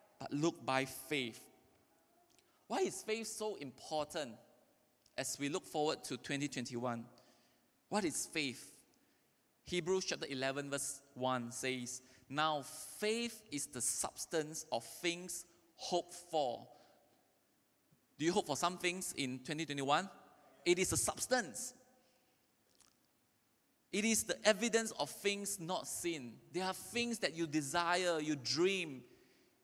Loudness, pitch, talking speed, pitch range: -39 LUFS, 160 Hz, 125 wpm, 140-190 Hz